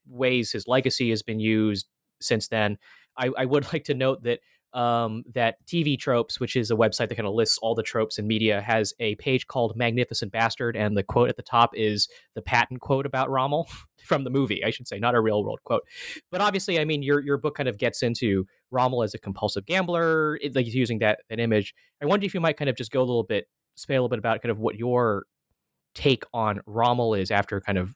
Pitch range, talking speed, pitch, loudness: 110-130 Hz, 240 wpm, 120 Hz, -25 LUFS